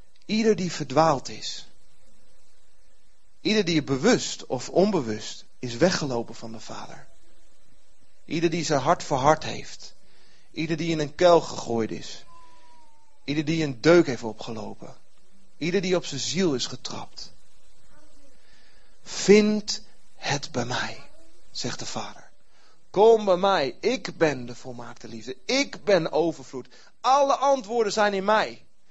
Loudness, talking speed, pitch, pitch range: -24 LUFS, 130 wpm, 165 Hz, 130-205 Hz